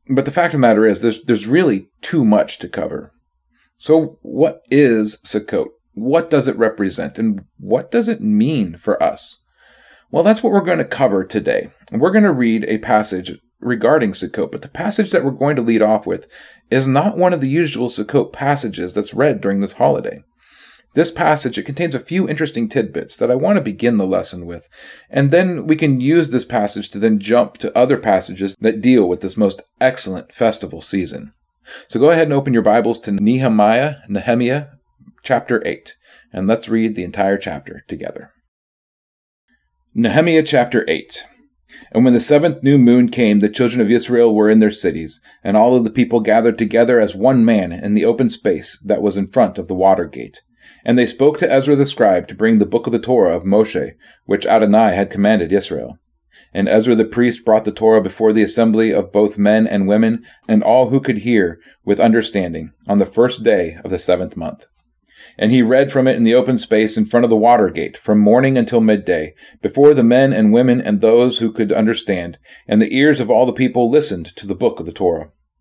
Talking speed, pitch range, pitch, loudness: 205 wpm, 105-140 Hz, 120 Hz, -15 LUFS